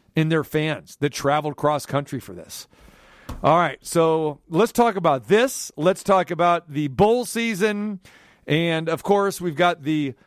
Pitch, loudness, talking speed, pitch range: 165 Hz, -21 LUFS, 165 wpm, 150-195 Hz